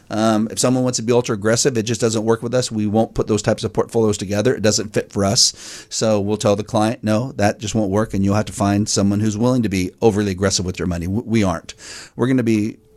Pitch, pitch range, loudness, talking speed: 110 Hz, 105-115 Hz, -18 LUFS, 270 wpm